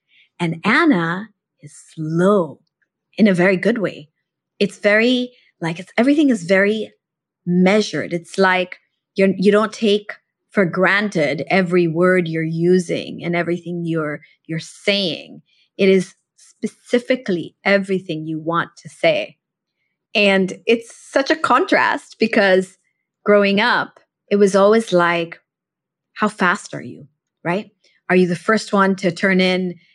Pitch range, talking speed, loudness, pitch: 170-210 Hz, 135 wpm, -17 LUFS, 190 Hz